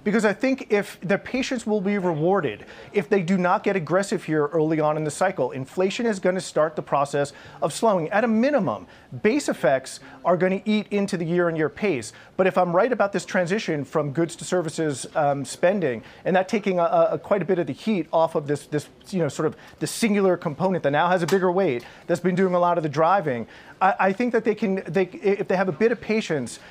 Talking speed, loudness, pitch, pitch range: 240 wpm, -23 LUFS, 185 Hz, 160-200 Hz